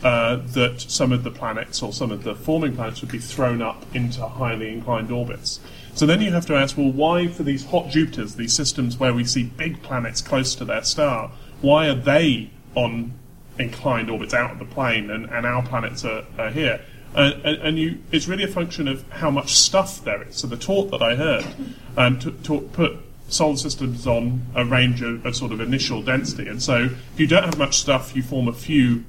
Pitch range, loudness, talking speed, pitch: 120-150 Hz, -21 LUFS, 220 wpm, 130 Hz